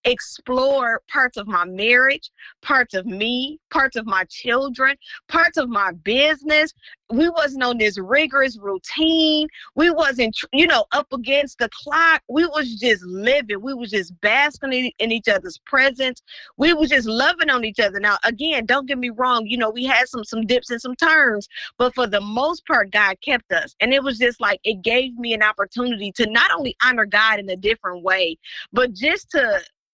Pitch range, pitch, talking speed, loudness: 220-290 Hz, 250 Hz, 190 wpm, -19 LUFS